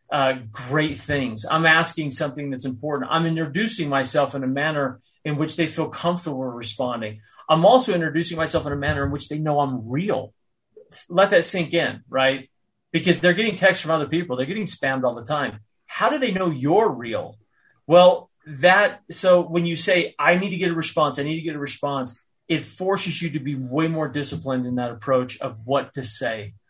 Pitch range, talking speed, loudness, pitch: 135-170 Hz, 200 wpm, -22 LUFS, 150 Hz